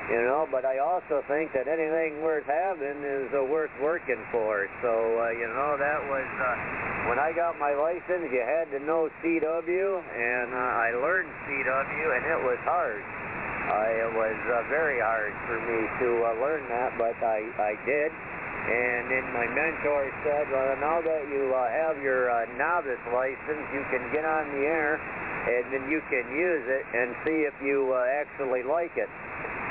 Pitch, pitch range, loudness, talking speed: 140 Hz, 120-155 Hz, -28 LUFS, 185 wpm